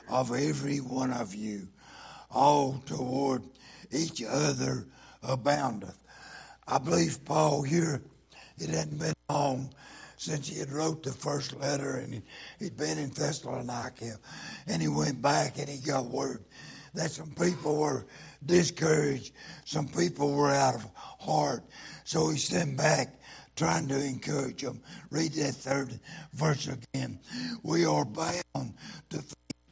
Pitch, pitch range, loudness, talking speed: 140 Hz, 130-155 Hz, -31 LUFS, 135 wpm